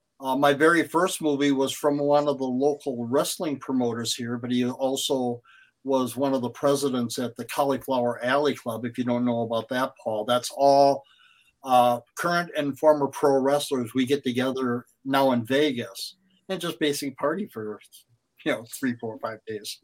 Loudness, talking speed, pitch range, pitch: -25 LUFS, 180 wpm, 120-145 Hz, 130 Hz